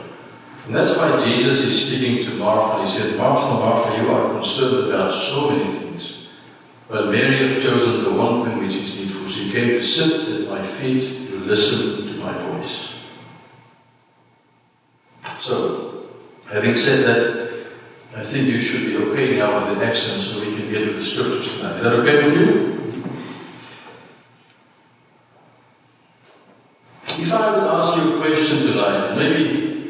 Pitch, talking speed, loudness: 150 Hz, 155 wpm, -18 LUFS